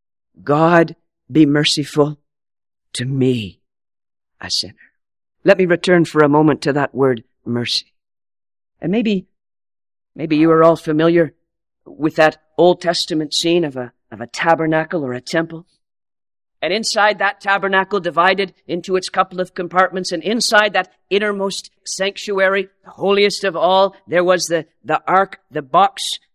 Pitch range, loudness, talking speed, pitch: 150-190 Hz, -16 LUFS, 145 wpm, 170 Hz